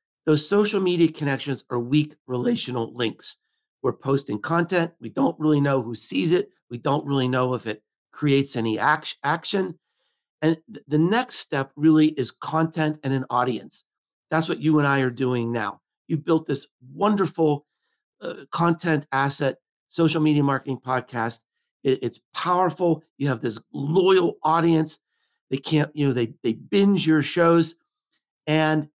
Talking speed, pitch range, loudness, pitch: 155 wpm, 130-165 Hz, -23 LUFS, 150 Hz